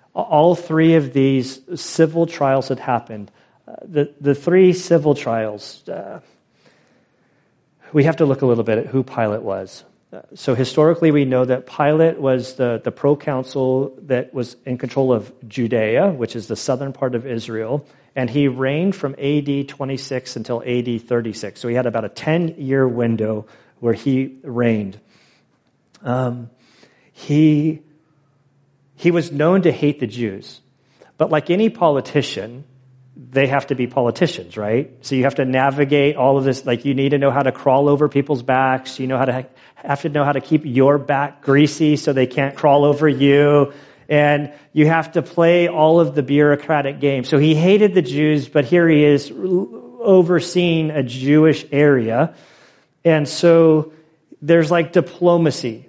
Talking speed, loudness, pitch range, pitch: 165 wpm, -17 LUFS, 130-155 Hz, 140 Hz